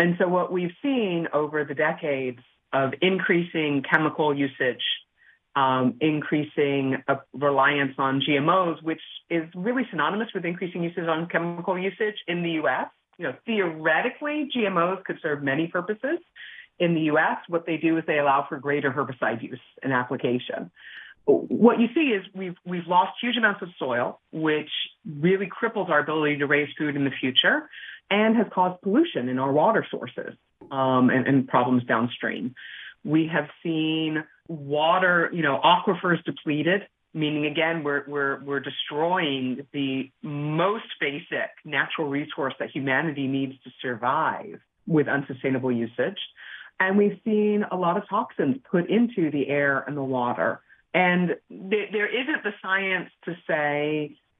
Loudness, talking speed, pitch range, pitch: -25 LUFS, 150 wpm, 140-185 Hz, 160 Hz